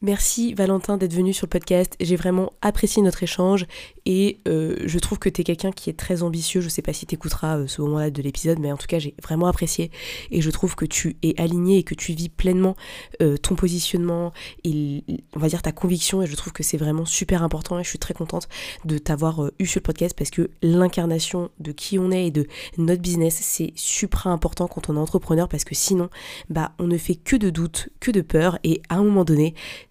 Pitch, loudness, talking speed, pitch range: 175 Hz, -23 LUFS, 240 wpm, 160-185 Hz